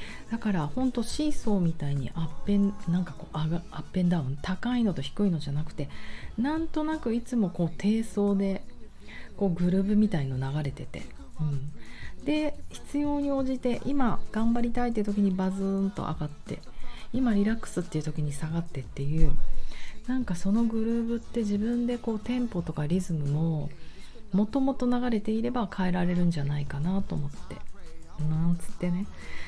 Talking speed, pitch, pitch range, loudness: 340 characters per minute, 195 Hz, 155-230 Hz, -29 LUFS